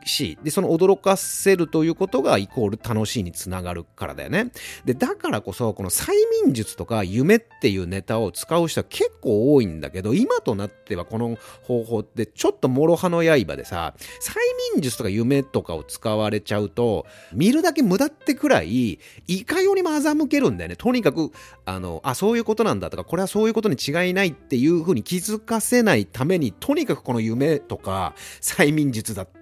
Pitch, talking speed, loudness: 150 Hz, 385 characters per minute, -22 LUFS